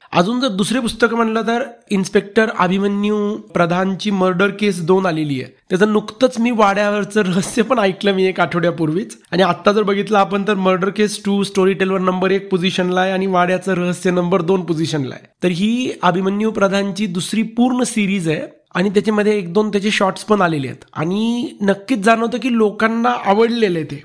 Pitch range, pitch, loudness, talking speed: 185-215 Hz, 200 Hz, -17 LUFS, 175 wpm